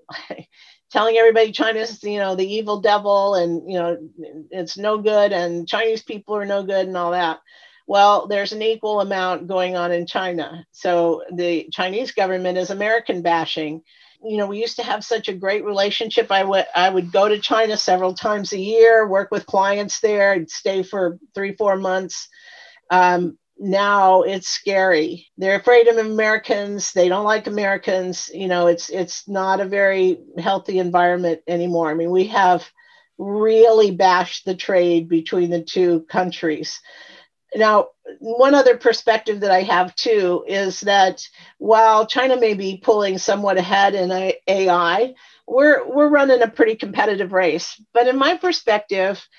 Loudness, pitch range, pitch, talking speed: -18 LUFS, 180-220 Hz, 195 Hz, 165 wpm